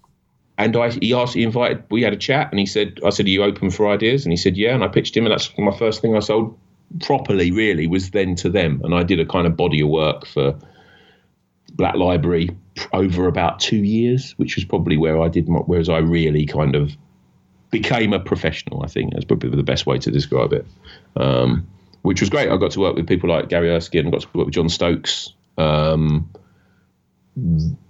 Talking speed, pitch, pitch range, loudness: 225 wpm, 90 Hz, 80-105 Hz, -19 LUFS